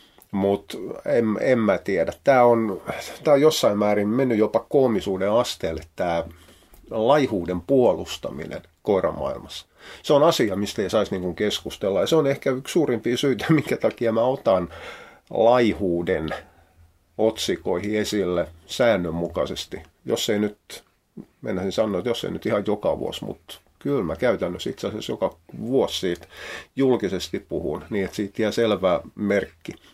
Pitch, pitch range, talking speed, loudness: 100 Hz, 85-110 Hz, 140 wpm, -23 LUFS